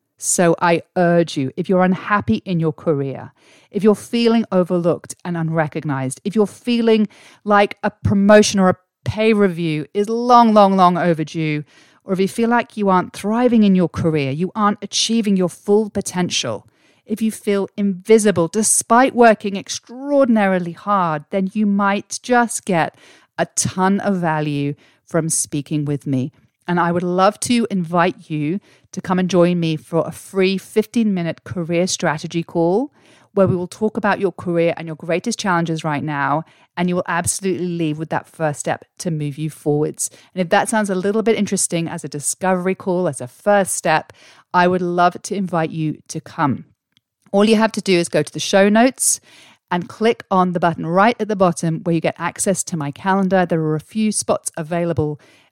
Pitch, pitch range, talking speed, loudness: 180 Hz, 165-205 Hz, 185 wpm, -18 LUFS